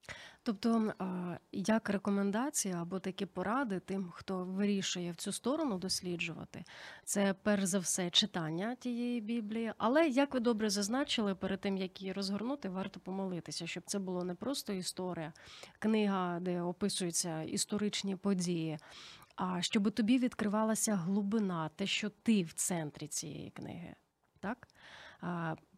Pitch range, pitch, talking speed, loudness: 180-220 Hz, 195 Hz, 130 wpm, -35 LUFS